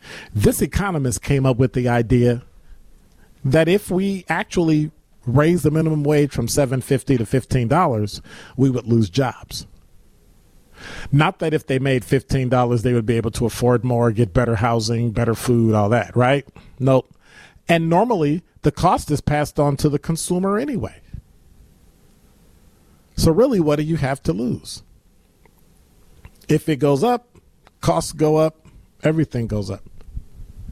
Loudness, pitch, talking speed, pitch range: -19 LUFS, 135 Hz, 145 wpm, 120-155 Hz